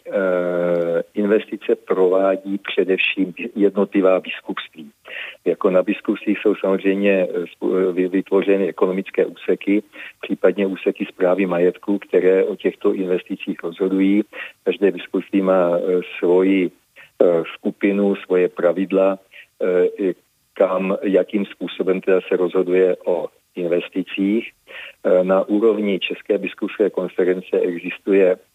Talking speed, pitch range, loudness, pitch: 90 wpm, 90-100 Hz, -19 LUFS, 95 Hz